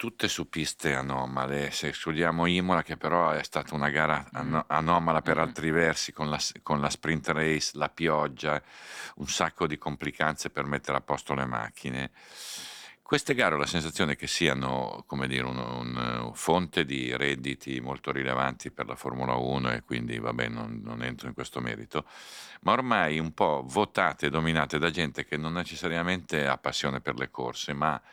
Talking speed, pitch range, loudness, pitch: 175 wpm, 65-80 Hz, -29 LUFS, 75 Hz